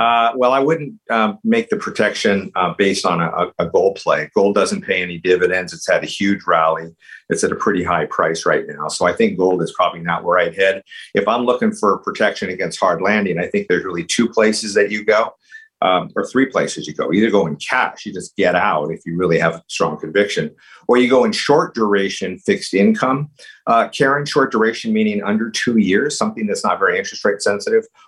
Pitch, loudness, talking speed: 130 Hz, -17 LUFS, 220 wpm